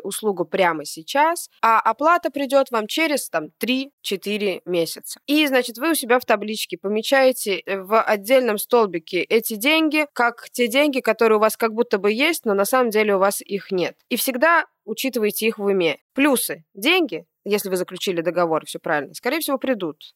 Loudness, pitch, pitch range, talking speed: -20 LUFS, 220 Hz, 195-265 Hz, 175 wpm